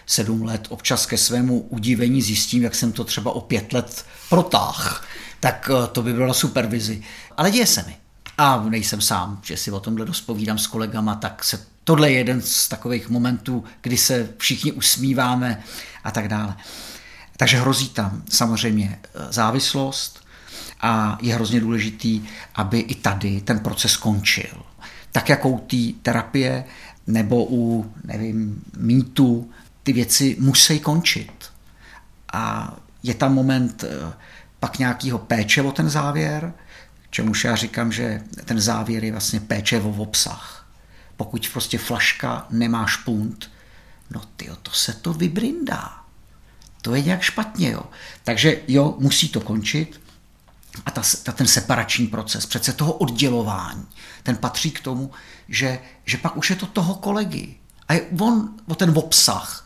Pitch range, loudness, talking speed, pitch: 110-135 Hz, -20 LUFS, 150 wpm, 120 Hz